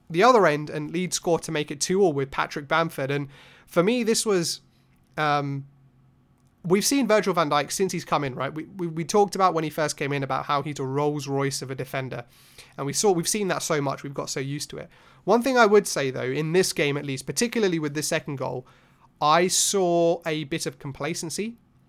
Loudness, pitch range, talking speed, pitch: -24 LUFS, 140-180 Hz, 235 wpm, 155 Hz